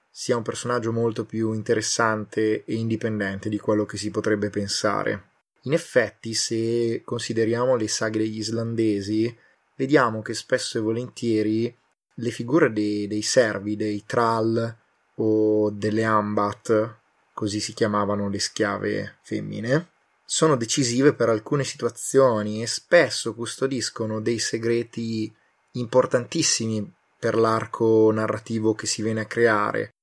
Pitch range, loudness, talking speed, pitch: 110-115 Hz, -24 LUFS, 125 wpm, 115 Hz